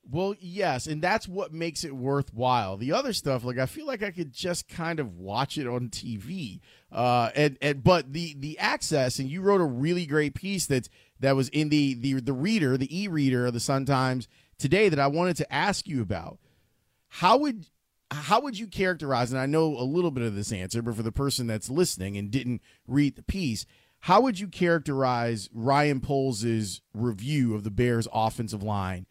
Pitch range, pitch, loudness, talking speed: 120-165 Hz, 135 Hz, -27 LUFS, 200 wpm